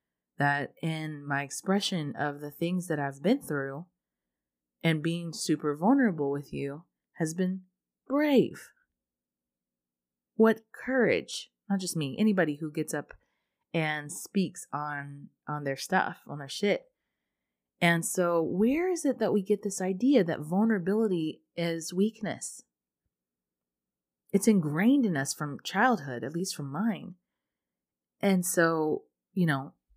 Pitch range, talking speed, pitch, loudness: 140-195 Hz, 130 wpm, 160 Hz, -29 LUFS